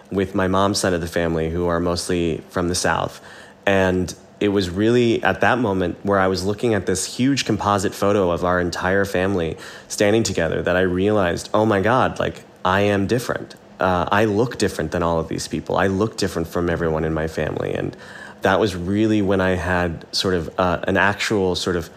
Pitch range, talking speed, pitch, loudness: 85-100 Hz, 210 wpm, 95 Hz, -20 LUFS